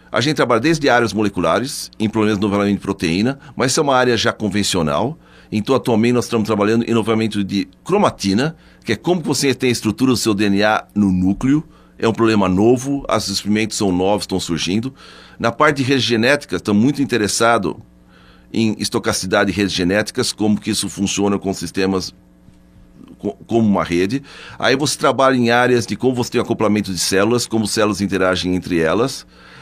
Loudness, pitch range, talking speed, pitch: -17 LUFS, 95-120 Hz, 180 wpm, 110 Hz